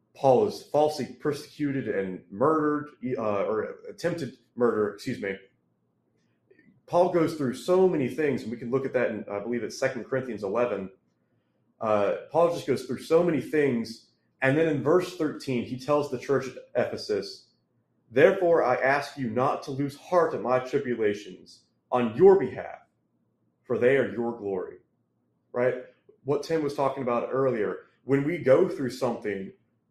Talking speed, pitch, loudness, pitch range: 165 wpm, 135 Hz, -27 LUFS, 120-155 Hz